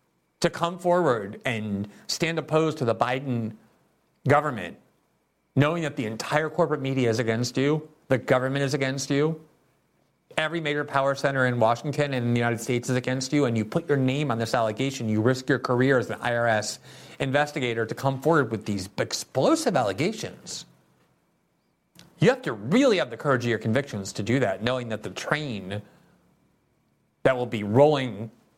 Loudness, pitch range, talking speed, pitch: -25 LUFS, 115-145 Hz, 170 wpm, 130 Hz